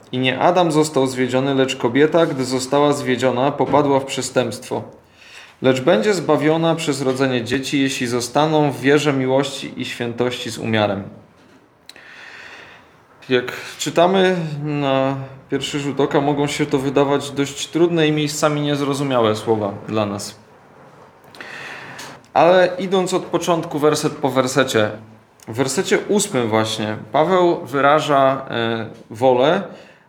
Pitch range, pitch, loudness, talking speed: 125-150 Hz, 140 Hz, -18 LUFS, 120 wpm